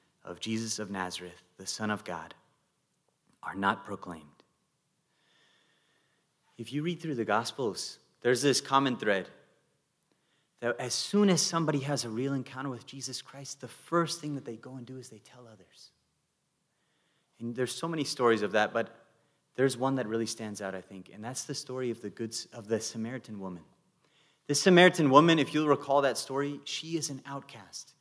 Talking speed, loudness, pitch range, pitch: 180 wpm, -30 LUFS, 110-145 Hz, 130 Hz